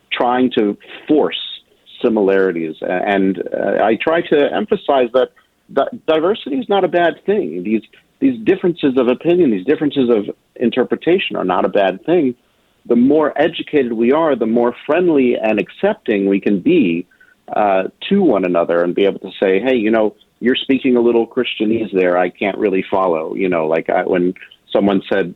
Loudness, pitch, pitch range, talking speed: -16 LUFS, 120 Hz, 100-150 Hz, 175 wpm